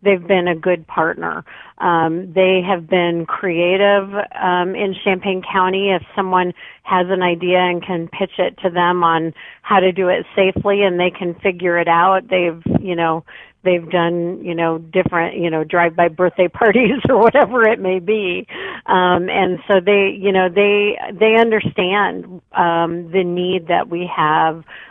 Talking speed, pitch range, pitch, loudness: 170 wpm, 175-195 Hz, 185 Hz, -16 LUFS